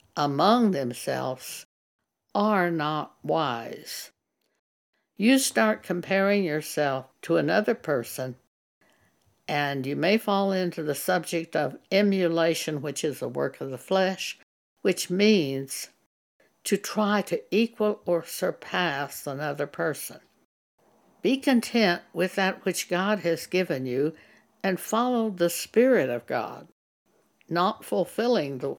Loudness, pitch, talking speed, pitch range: -26 LUFS, 180 Hz, 115 wpm, 150-210 Hz